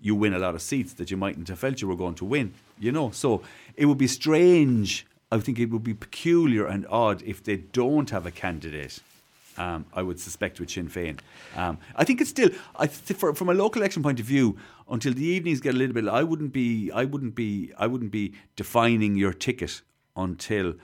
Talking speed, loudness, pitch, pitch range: 230 wpm, -26 LUFS, 110 Hz, 95-135 Hz